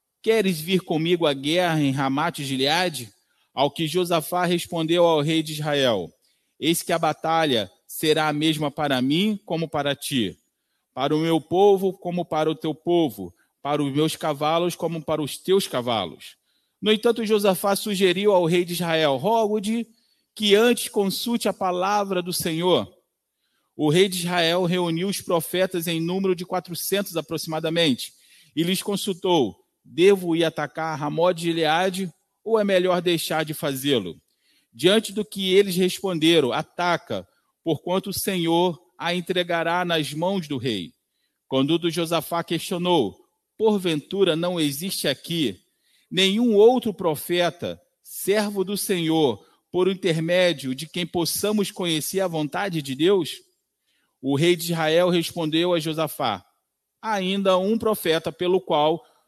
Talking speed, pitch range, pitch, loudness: 145 wpm, 160-190 Hz, 175 Hz, -23 LUFS